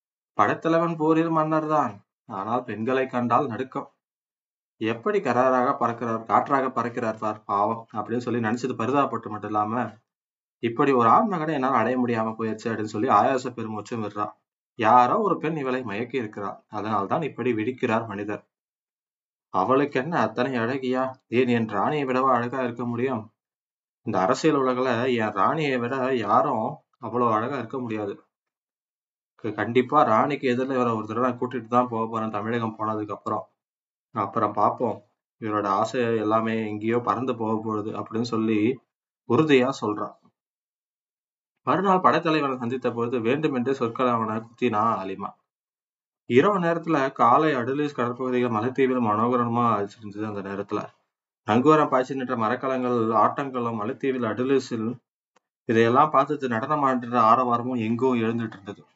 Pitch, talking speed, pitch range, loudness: 120 Hz, 125 wpm, 110-130 Hz, -24 LUFS